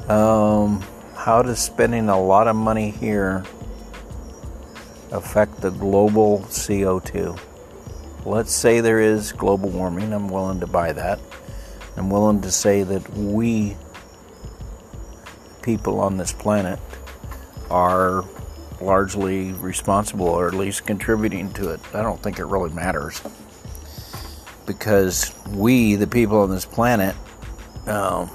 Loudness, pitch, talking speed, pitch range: -20 LUFS, 100 Hz, 120 wpm, 95-105 Hz